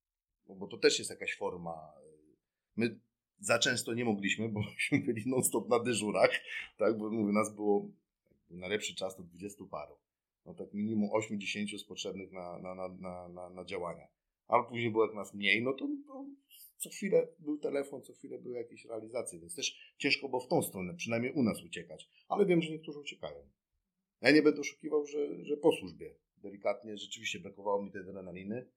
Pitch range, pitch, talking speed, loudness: 100-150 Hz, 110 Hz, 175 wpm, -34 LUFS